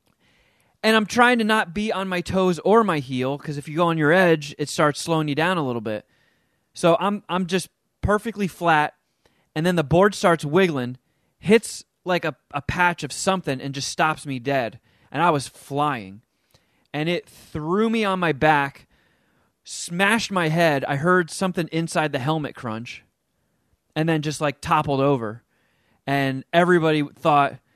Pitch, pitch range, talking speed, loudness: 160 Hz, 140-185 Hz, 175 wpm, -22 LUFS